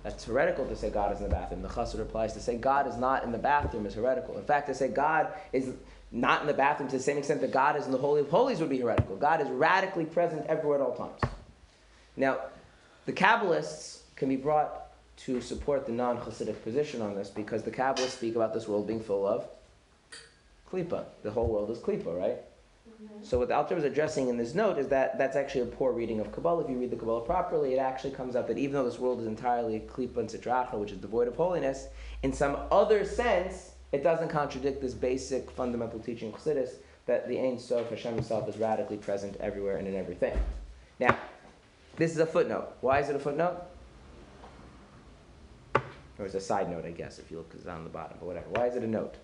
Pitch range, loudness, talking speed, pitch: 110-145 Hz, -30 LUFS, 225 wpm, 125 Hz